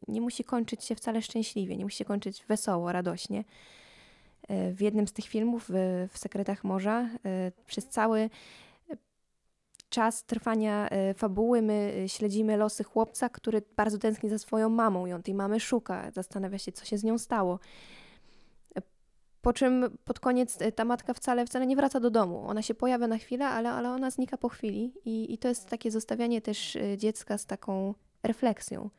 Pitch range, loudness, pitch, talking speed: 205-235 Hz, -31 LUFS, 220 Hz, 165 wpm